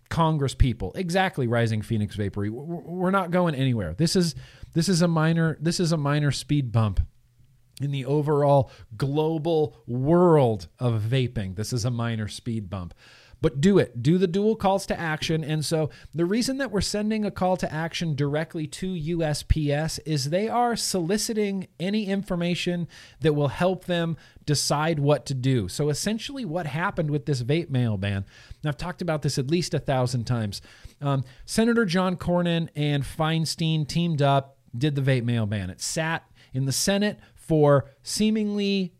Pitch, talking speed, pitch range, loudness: 150 Hz, 170 wpm, 125-175 Hz, -25 LUFS